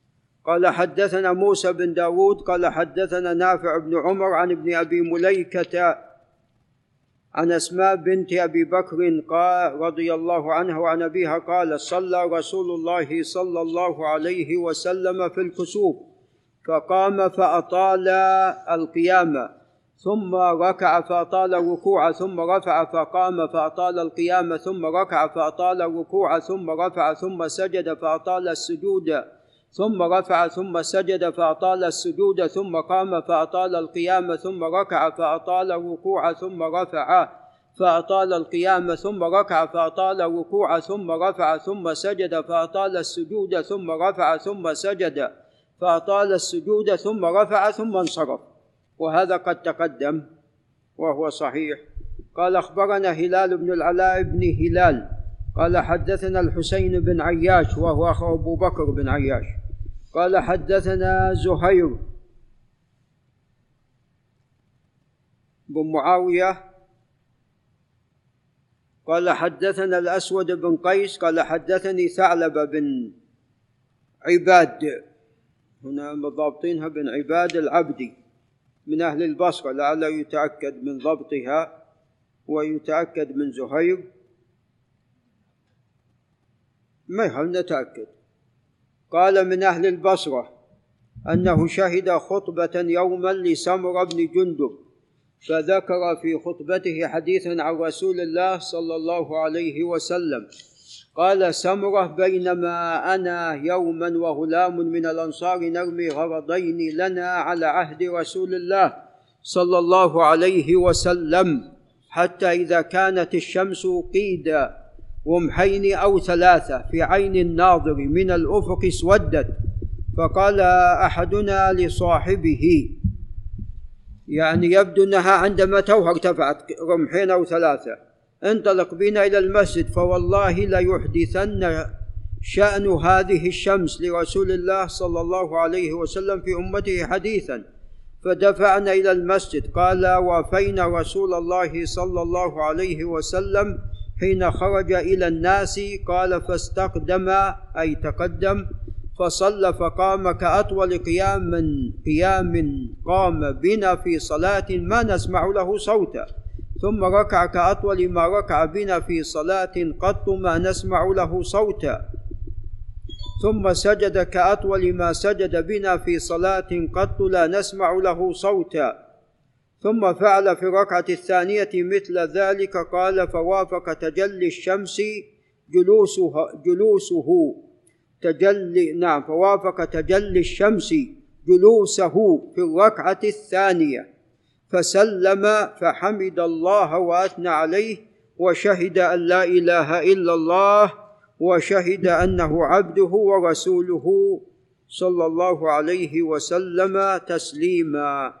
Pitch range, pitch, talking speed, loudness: 160-190 Hz, 175 Hz, 105 wpm, -21 LUFS